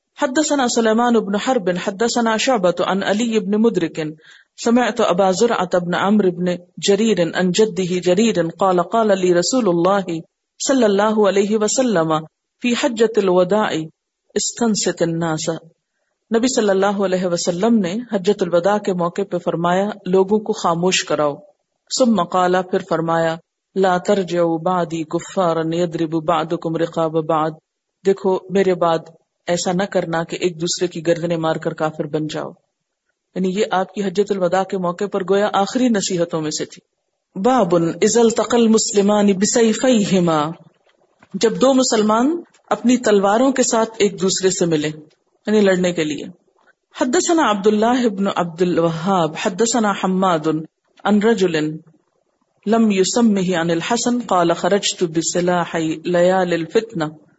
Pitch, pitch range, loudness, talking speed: 190 Hz, 170-220 Hz, -18 LUFS, 135 wpm